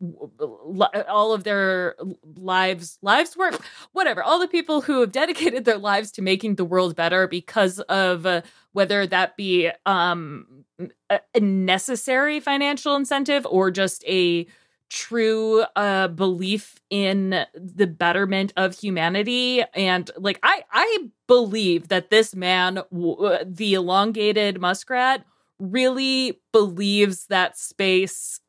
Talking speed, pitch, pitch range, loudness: 120 wpm, 195 Hz, 185-235 Hz, -21 LUFS